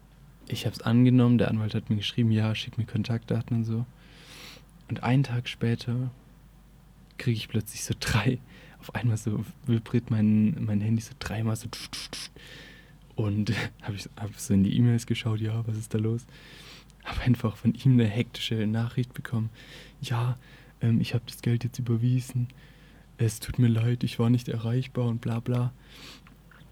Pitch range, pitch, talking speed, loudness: 115-130 Hz, 120 Hz, 165 wpm, -28 LUFS